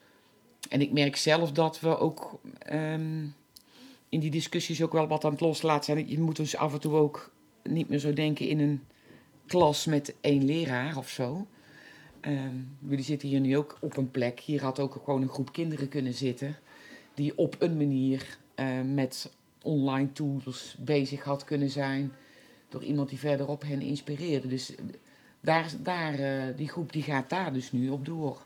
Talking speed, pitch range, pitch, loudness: 180 wpm, 135-155 Hz, 145 Hz, -30 LUFS